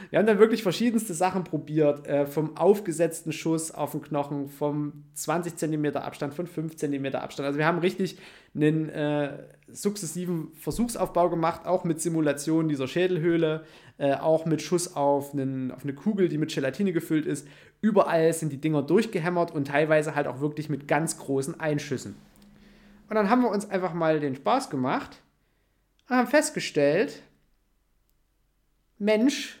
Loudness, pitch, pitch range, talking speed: -26 LUFS, 160 Hz, 145-185 Hz, 160 wpm